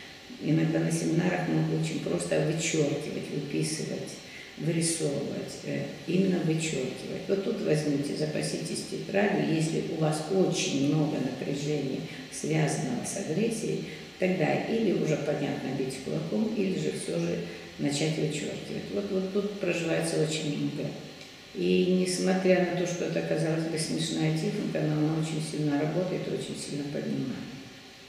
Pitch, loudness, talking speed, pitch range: 155 Hz, -29 LUFS, 130 wpm, 135-185 Hz